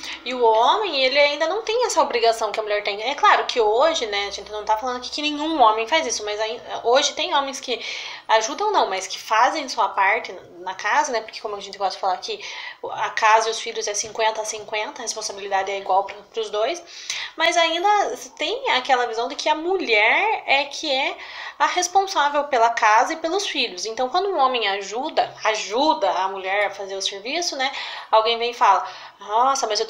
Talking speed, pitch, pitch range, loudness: 220 wpm, 250 Hz, 215-325 Hz, -21 LUFS